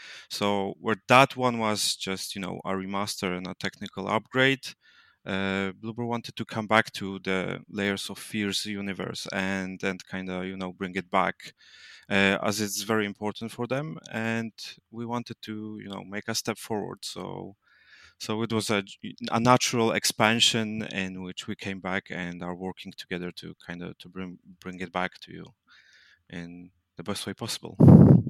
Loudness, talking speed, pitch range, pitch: -27 LUFS, 175 wpm, 95-110 Hz, 100 Hz